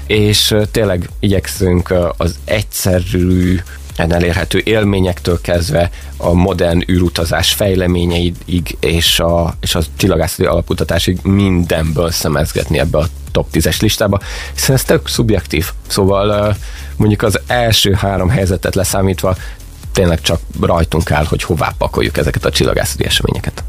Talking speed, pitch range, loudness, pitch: 120 wpm, 85-95 Hz, -14 LUFS, 90 Hz